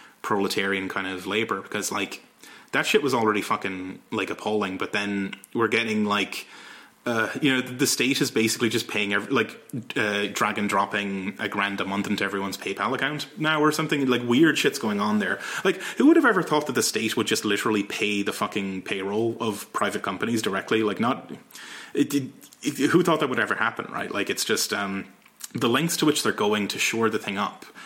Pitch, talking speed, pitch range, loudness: 105 Hz, 210 wpm, 100-125 Hz, -24 LUFS